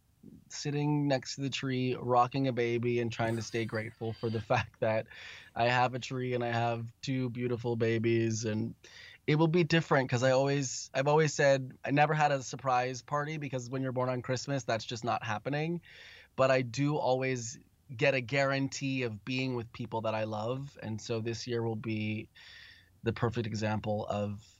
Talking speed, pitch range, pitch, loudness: 190 wpm, 115-135 Hz, 125 Hz, -32 LUFS